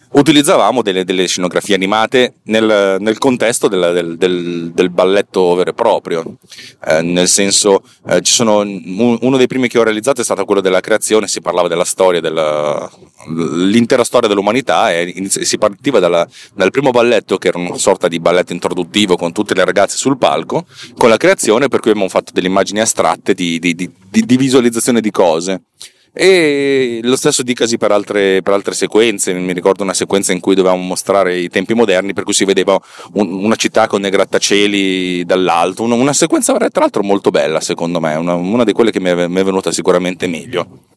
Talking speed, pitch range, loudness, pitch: 185 wpm, 90-115 Hz, -13 LUFS, 100 Hz